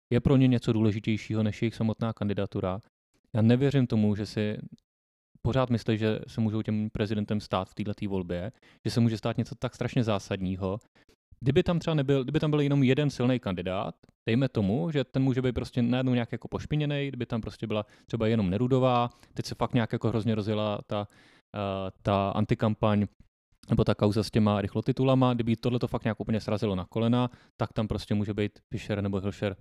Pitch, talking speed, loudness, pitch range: 110 Hz, 195 wpm, -28 LUFS, 105-125 Hz